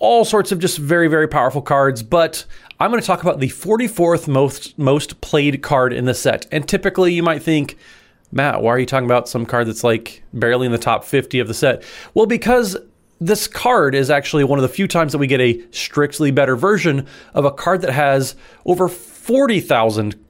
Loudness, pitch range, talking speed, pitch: -17 LUFS, 130-180 Hz, 215 wpm, 145 Hz